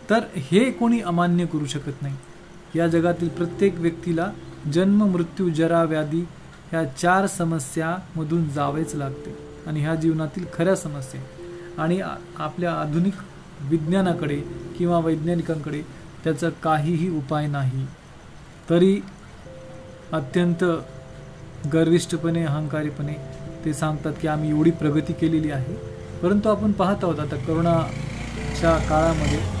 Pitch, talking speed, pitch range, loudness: 165 Hz, 110 wpm, 150-175 Hz, -23 LUFS